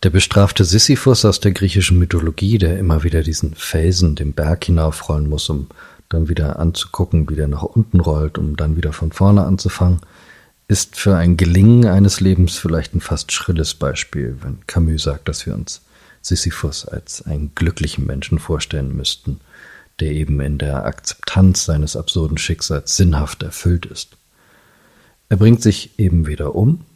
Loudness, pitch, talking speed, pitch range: -16 LUFS, 85 Hz, 160 wpm, 75-95 Hz